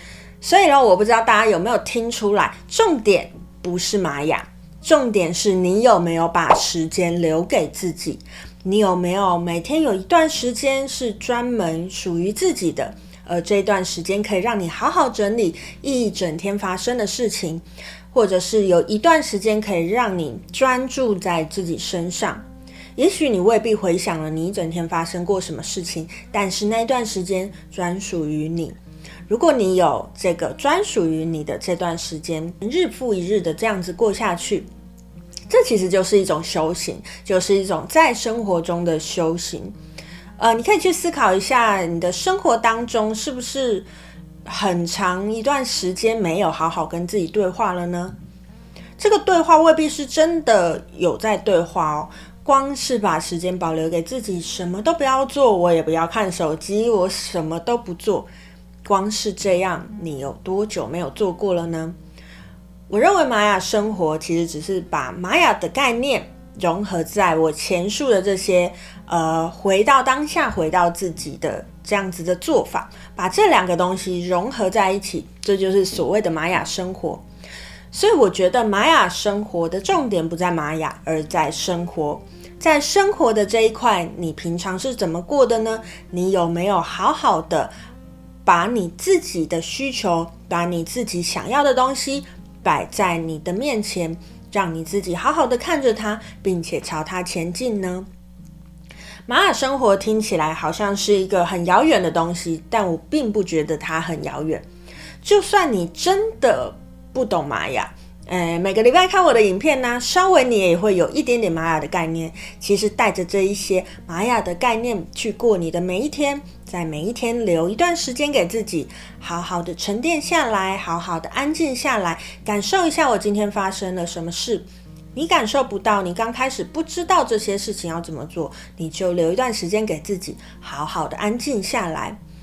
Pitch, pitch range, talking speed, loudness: 190 Hz, 170-230 Hz, 255 characters per minute, -20 LUFS